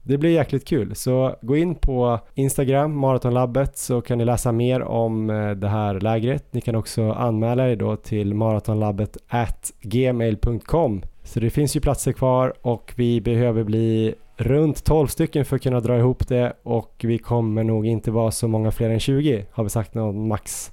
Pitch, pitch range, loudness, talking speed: 120 Hz, 110-130 Hz, -22 LUFS, 180 wpm